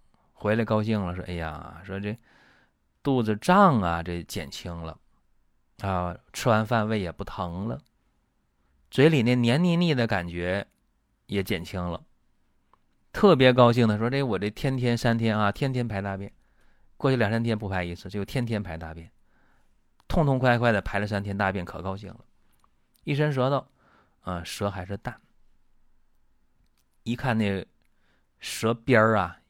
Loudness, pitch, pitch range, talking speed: -26 LUFS, 105 Hz, 90-120 Hz, 215 characters per minute